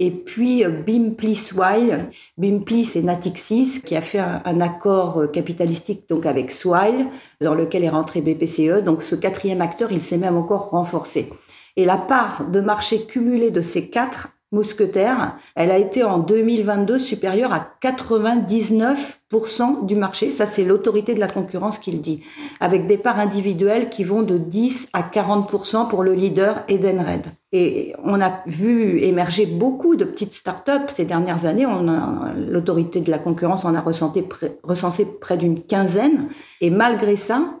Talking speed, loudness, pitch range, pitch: 160 wpm, -20 LUFS, 175-225 Hz, 200 Hz